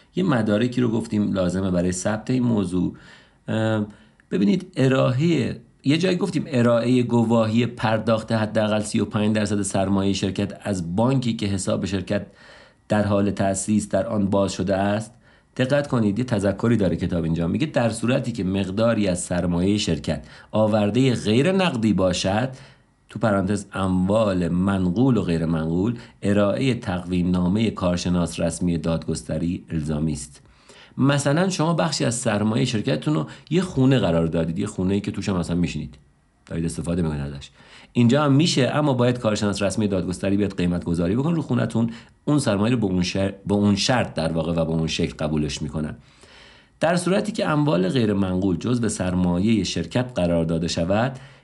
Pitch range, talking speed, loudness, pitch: 90-120 Hz, 155 wpm, -22 LUFS, 105 Hz